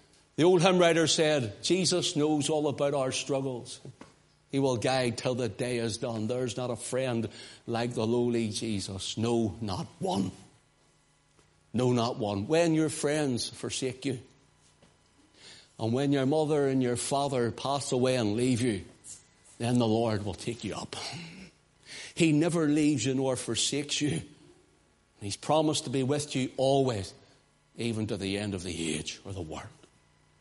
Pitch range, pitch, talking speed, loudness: 110-140 Hz, 125 Hz, 160 wpm, -29 LUFS